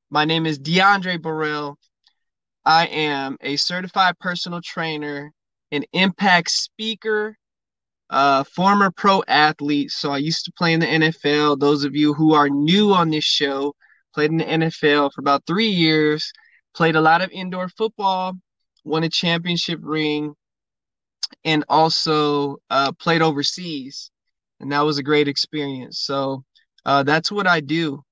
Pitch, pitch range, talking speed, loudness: 155 Hz, 145-180 Hz, 150 wpm, -19 LUFS